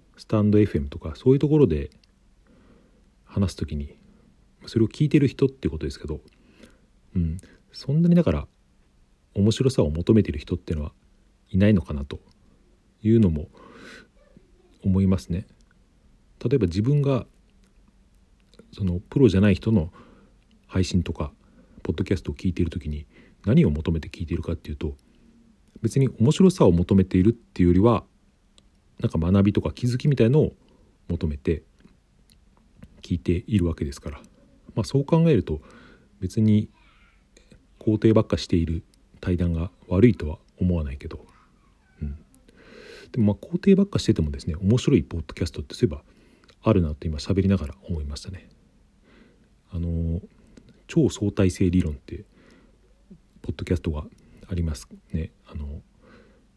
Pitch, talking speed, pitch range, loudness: 95 Hz, 280 characters per minute, 80-110 Hz, -24 LUFS